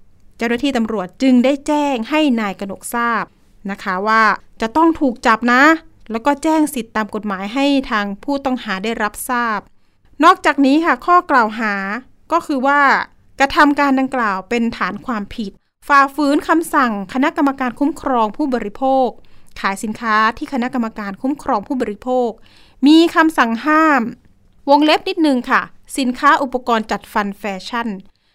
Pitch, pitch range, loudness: 250 Hz, 220-285 Hz, -16 LUFS